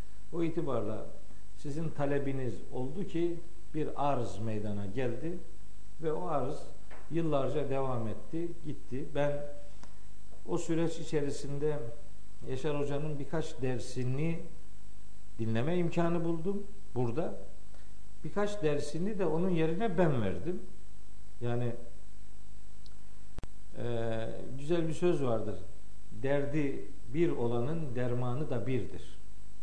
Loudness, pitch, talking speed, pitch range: -35 LUFS, 145 Hz, 95 wpm, 120-165 Hz